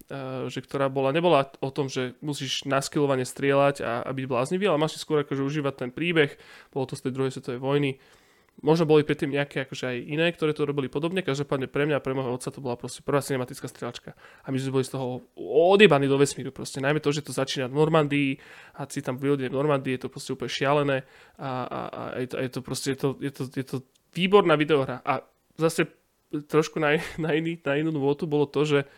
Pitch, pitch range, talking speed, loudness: 140 Hz, 135-150 Hz, 205 wpm, -26 LUFS